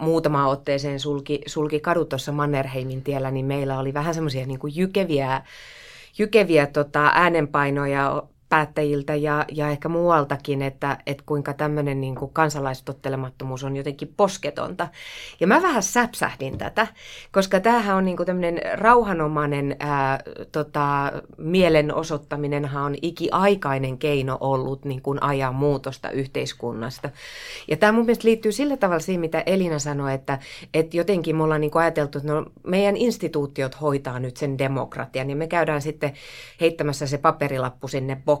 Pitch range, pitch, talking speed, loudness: 140-165 Hz, 145 Hz, 140 wpm, -23 LUFS